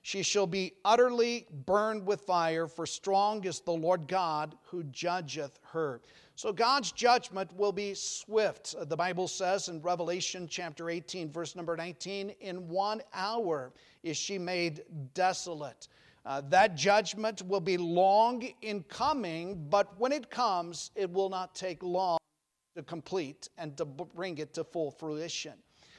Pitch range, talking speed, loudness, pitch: 165-200 Hz, 150 wpm, -32 LUFS, 180 Hz